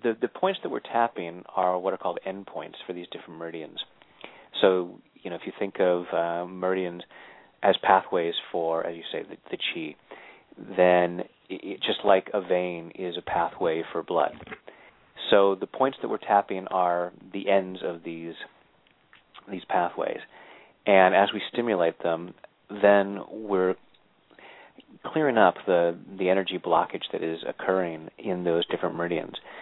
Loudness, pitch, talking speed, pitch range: -26 LUFS, 90 Hz, 160 wpm, 85-95 Hz